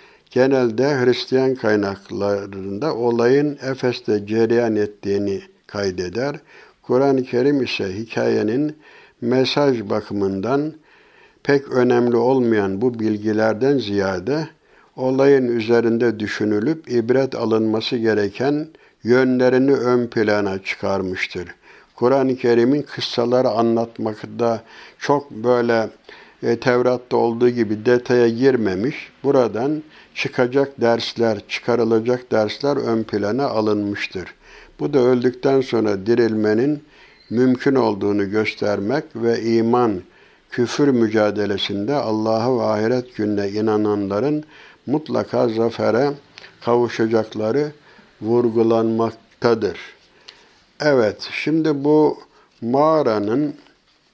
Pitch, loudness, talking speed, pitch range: 120 Hz, -19 LUFS, 85 wpm, 110-135 Hz